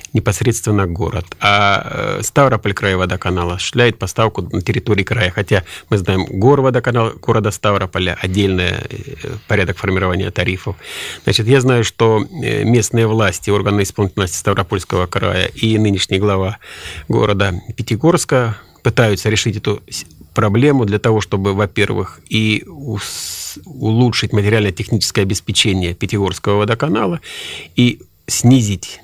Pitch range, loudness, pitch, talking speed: 100-115 Hz, -16 LUFS, 105 Hz, 110 wpm